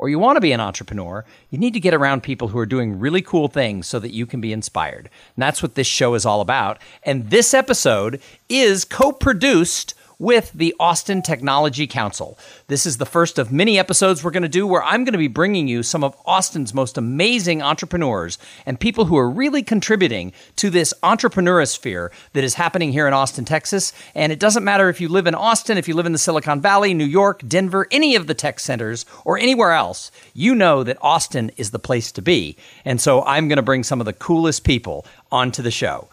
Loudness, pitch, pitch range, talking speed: -18 LUFS, 155 Hz, 130-190 Hz, 220 wpm